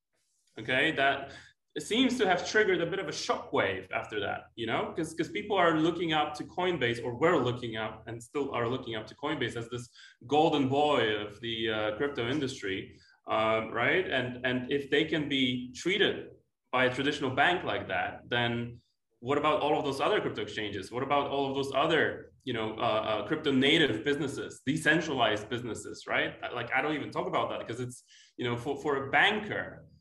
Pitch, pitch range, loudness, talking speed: 135 Hz, 120-150 Hz, -30 LUFS, 200 wpm